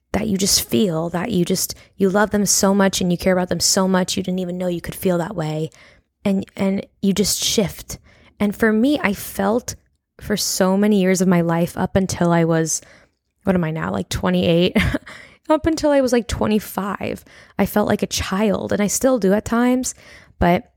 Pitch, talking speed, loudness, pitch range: 195 Hz, 210 wpm, -19 LUFS, 175-210 Hz